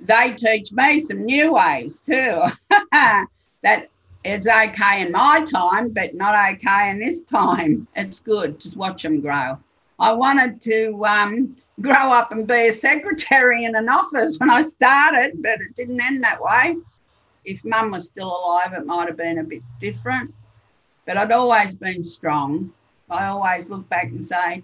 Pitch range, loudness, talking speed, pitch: 180-255 Hz, -18 LUFS, 170 wpm, 215 Hz